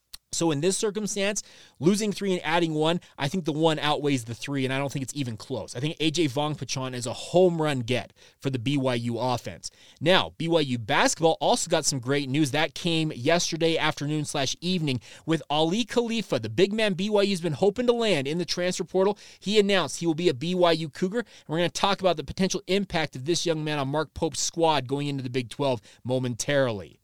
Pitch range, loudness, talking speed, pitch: 140-180 Hz, -26 LUFS, 215 wpm, 160 Hz